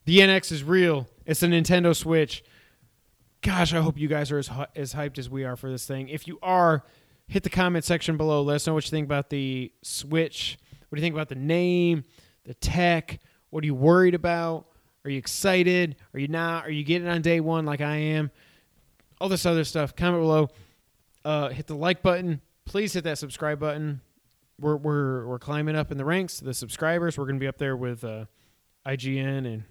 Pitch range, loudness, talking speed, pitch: 135-170 Hz, -25 LUFS, 215 wpm, 150 Hz